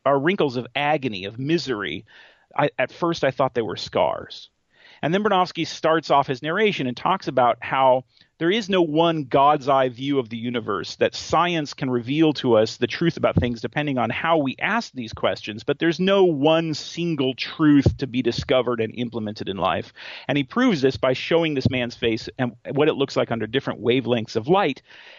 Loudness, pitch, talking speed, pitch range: -22 LUFS, 135 Hz, 200 wpm, 120-160 Hz